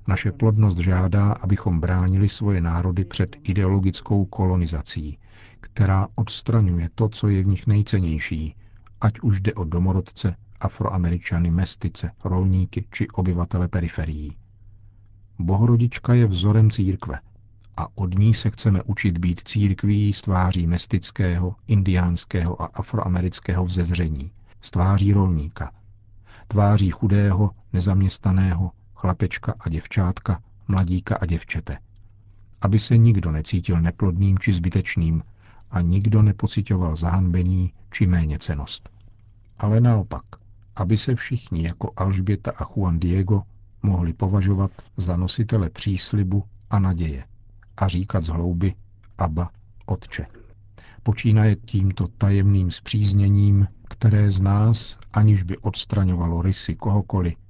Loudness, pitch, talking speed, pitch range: -22 LUFS, 100 Hz, 110 wpm, 90-105 Hz